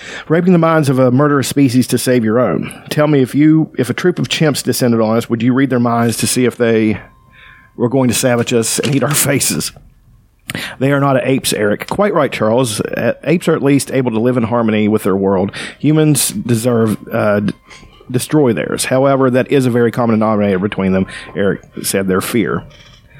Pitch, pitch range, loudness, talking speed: 125 Hz, 115-140 Hz, -14 LUFS, 205 wpm